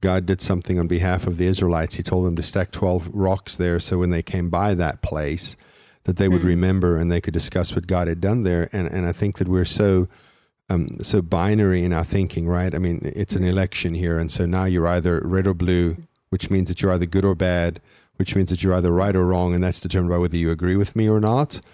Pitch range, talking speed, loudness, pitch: 85-95 Hz, 250 wpm, -21 LUFS, 90 Hz